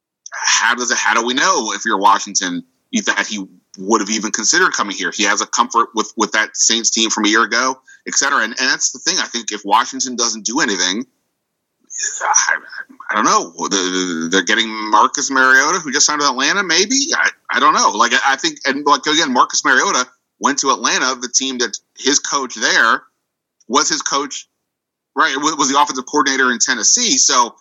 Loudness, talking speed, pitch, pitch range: -15 LUFS, 200 wpm, 130 Hz, 110-155 Hz